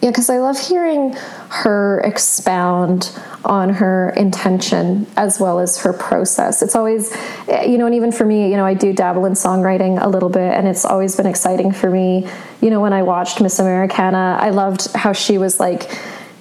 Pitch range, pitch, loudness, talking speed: 185-220 Hz, 195 Hz, -15 LUFS, 195 wpm